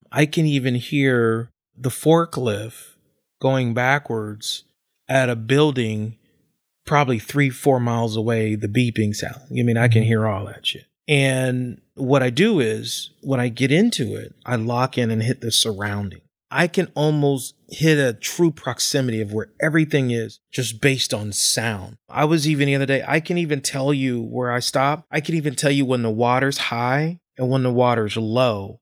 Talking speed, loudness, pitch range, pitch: 180 wpm, -20 LUFS, 115-145 Hz, 125 Hz